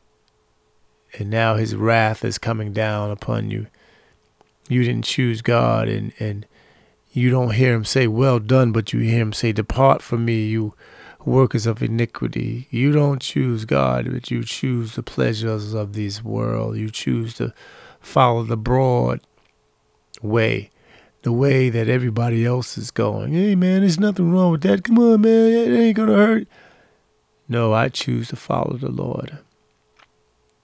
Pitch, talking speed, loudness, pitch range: 115 Hz, 160 wpm, -19 LUFS, 110-130 Hz